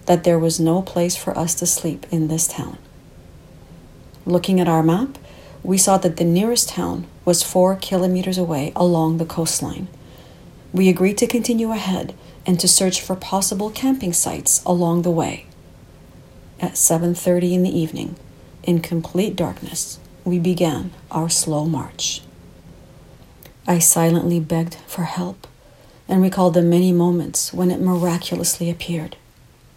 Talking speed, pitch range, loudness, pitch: 145 wpm, 165-185 Hz, -19 LUFS, 175 Hz